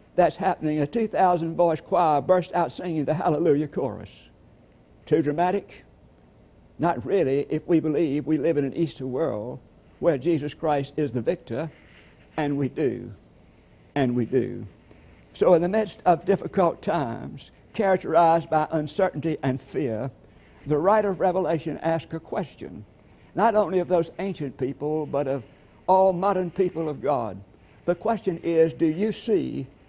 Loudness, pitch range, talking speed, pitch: -24 LUFS, 140-180 Hz, 155 wpm, 160 Hz